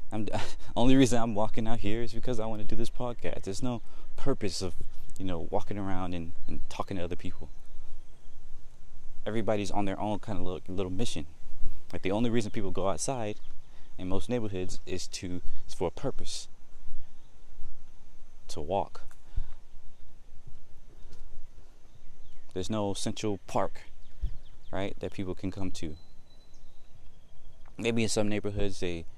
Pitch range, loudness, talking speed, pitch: 90-110 Hz, -34 LUFS, 145 wpm, 100 Hz